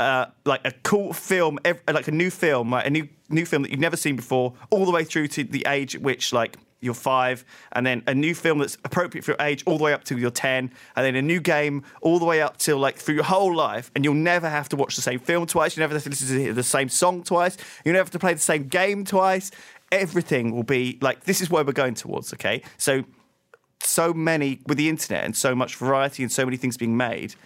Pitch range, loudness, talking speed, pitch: 130-170 Hz, -23 LUFS, 260 wpm, 150 Hz